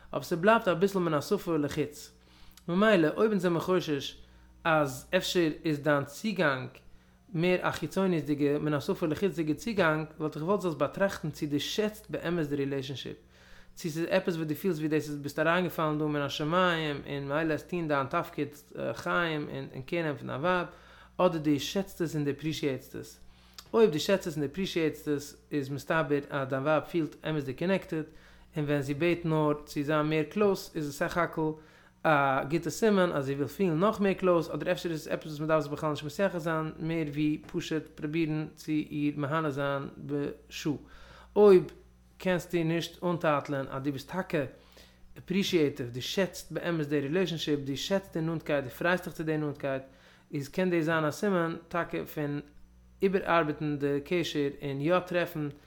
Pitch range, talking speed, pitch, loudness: 145-175 Hz, 195 wpm, 155 Hz, -30 LUFS